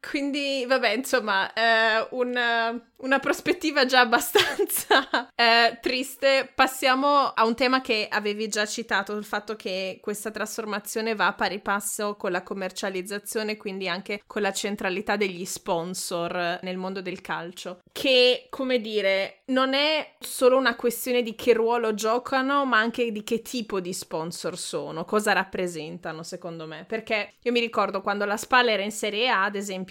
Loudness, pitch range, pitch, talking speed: -24 LUFS, 195-250 Hz, 220 Hz, 160 wpm